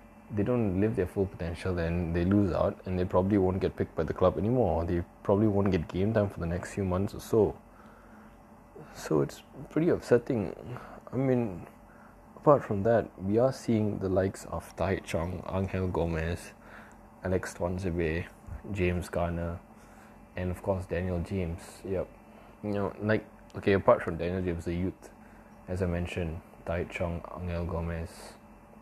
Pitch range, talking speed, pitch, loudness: 85-105 Hz, 165 wpm, 95 Hz, -30 LUFS